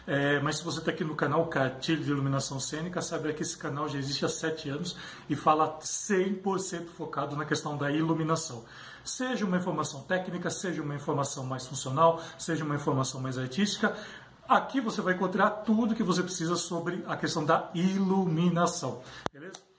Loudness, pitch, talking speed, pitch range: -30 LUFS, 165 Hz, 175 wpm, 145-180 Hz